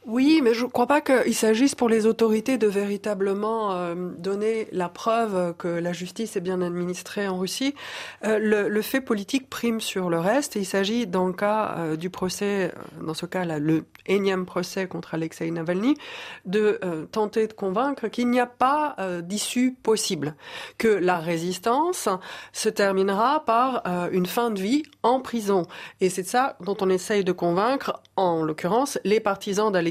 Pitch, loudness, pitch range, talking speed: 205 Hz, -24 LUFS, 180-230 Hz, 185 wpm